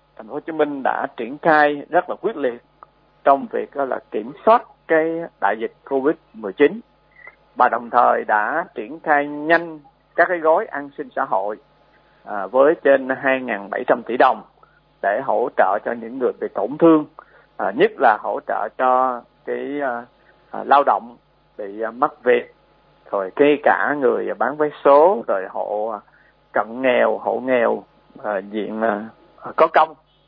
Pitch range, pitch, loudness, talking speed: 130-165 Hz, 145 Hz, -19 LUFS, 165 wpm